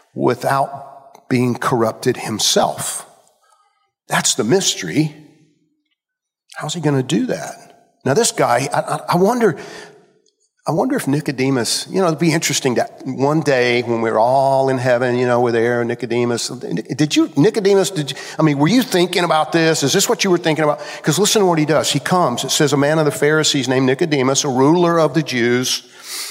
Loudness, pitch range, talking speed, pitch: -16 LUFS, 130-175 Hz, 190 wpm, 150 Hz